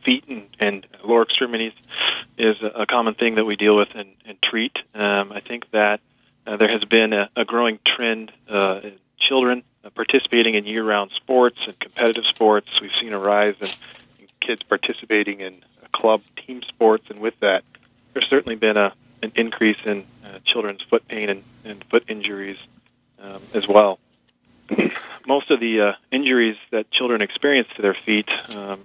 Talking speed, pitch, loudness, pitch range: 175 wpm, 110 Hz, -20 LUFS, 105-120 Hz